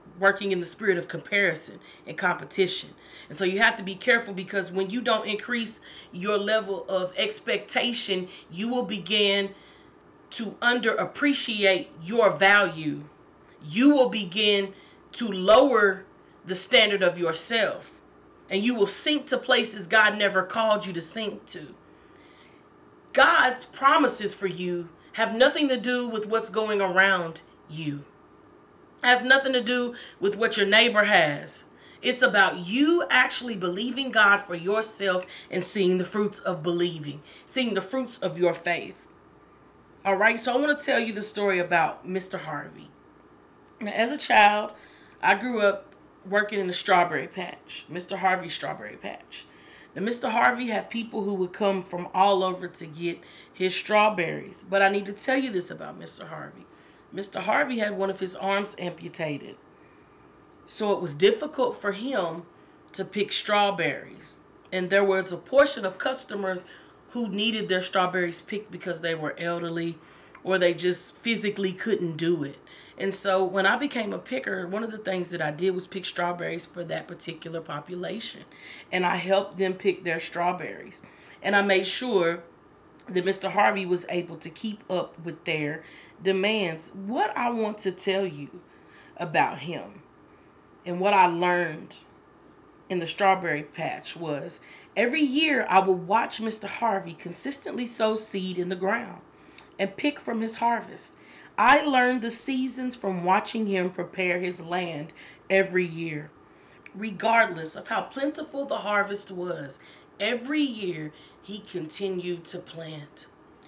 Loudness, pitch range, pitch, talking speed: -25 LUFS, 175-220 Hz, 195 Hz, 155 wpm